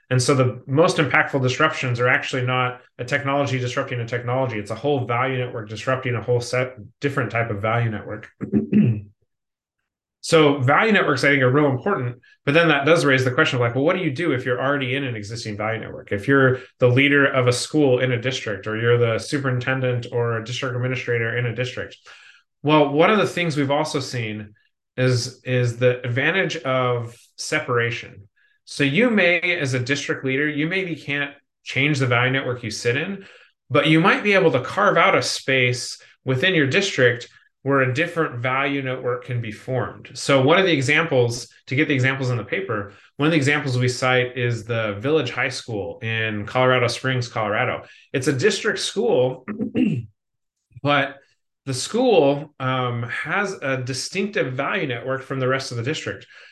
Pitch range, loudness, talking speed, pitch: 120-145 Hz, -21 LUFS, 190 wpm, 130 Hz